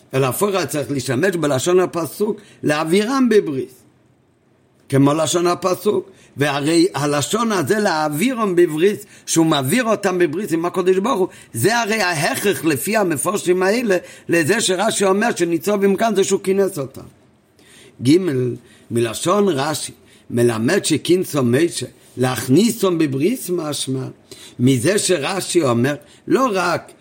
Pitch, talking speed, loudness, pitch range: 175 Hz, 120 wpm, -18 LUFS, 140-195 Hz